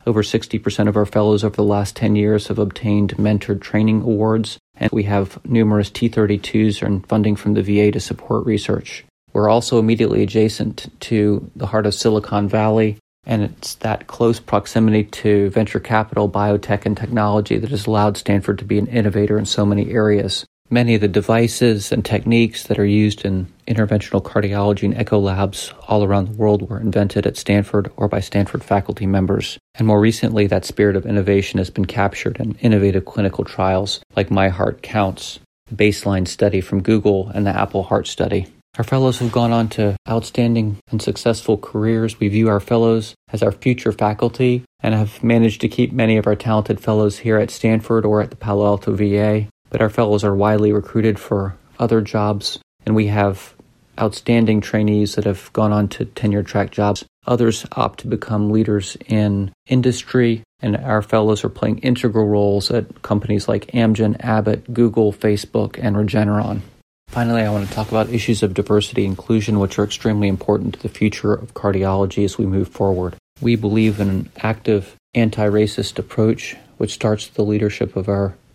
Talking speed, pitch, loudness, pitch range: 180 wpm, 105 Hz, -18 LUFS, 100-110 Hz